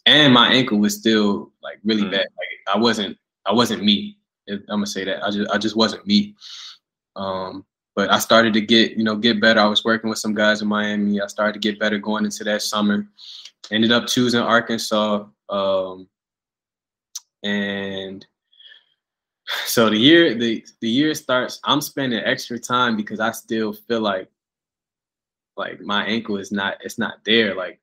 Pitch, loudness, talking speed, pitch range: 110 Hz, -19 LUFS, 175 wpm, 105-115 Hz